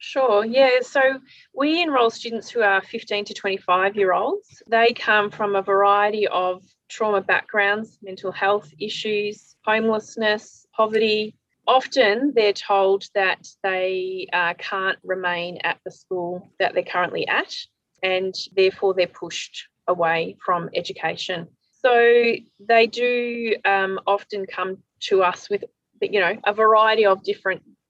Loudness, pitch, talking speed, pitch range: -21 LUFS, 205 Hz, 135 wpm, 185-225 Hz